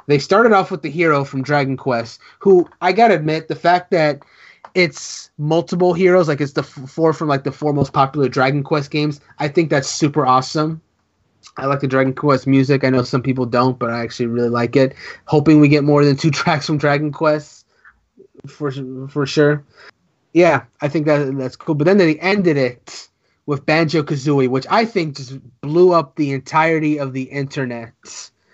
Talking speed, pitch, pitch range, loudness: 195 wpm, 145 Hz, 135-160 Hz, -17 LUFS